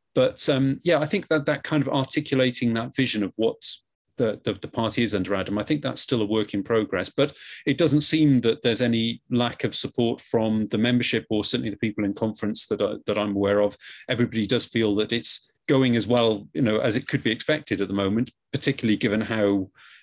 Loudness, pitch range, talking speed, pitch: -24 LUFS, 105-135 Hz, 225 wpm, 115 Hz